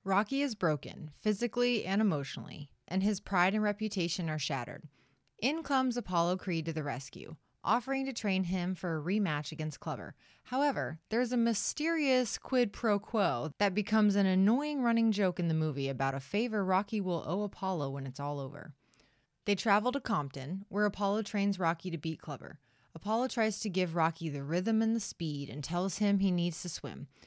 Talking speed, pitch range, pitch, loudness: 185 wpm, 155-215 Hz, 190 Hz, -32 LUFS